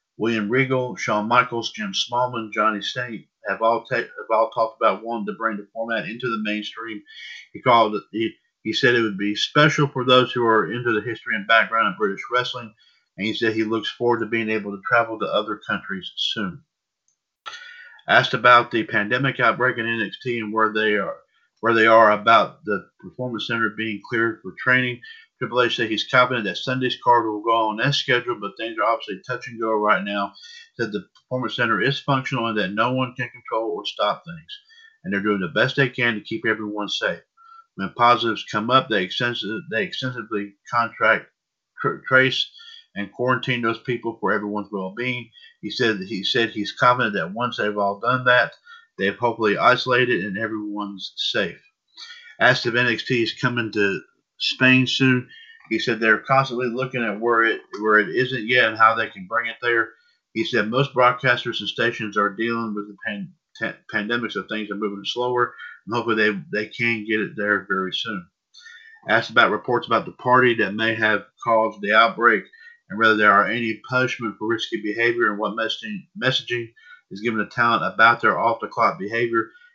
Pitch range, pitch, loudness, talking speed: 110-130 Hz, 120 Hz, -21 LUFS, 190 wpm